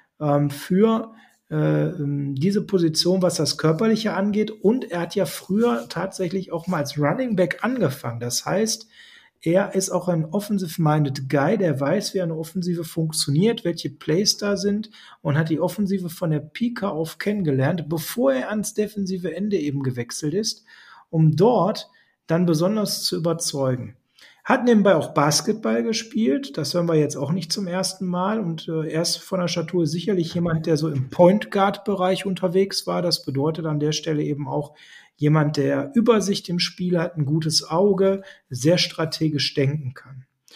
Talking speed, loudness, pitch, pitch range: 165 wpm, -22 LUFS, 175 Hz, 150-195 Hz